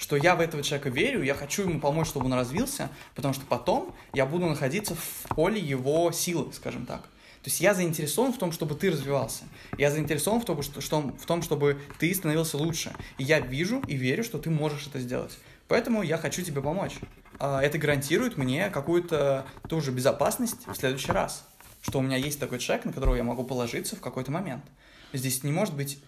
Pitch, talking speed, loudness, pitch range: 145 Hz, 205 wpm, -28 LUFS, 135-170 Hz